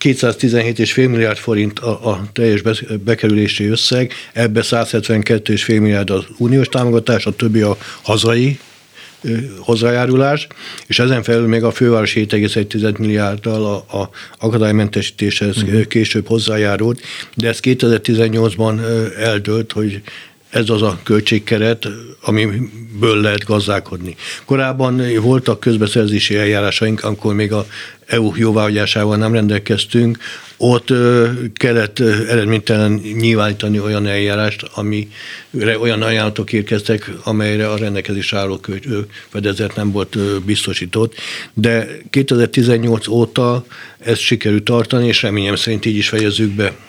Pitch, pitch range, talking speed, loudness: 110 Hz, 105-115 Hz, 110 wpm, -15 LUFS